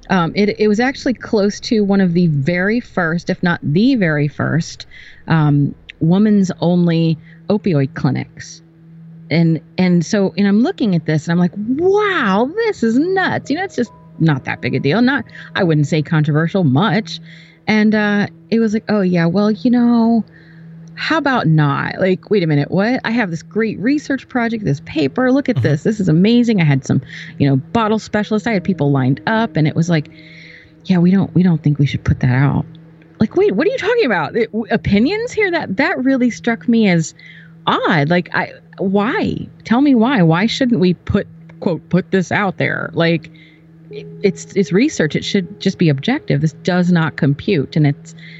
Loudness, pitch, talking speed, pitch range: -16 LUFS, 180 Hz, 195 wpm, 160-220 Hz